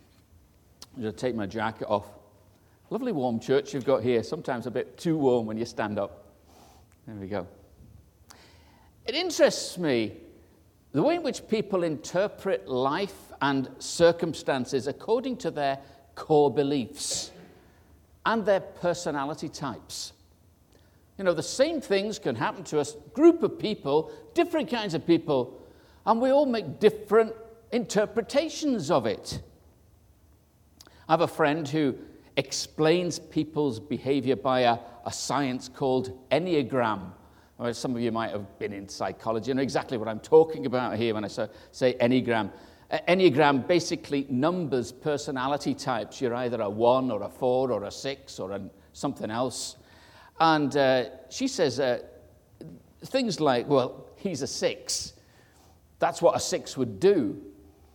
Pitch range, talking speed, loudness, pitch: 110-175 Hz, 145 wpm, -27 LUFS, 135 Hz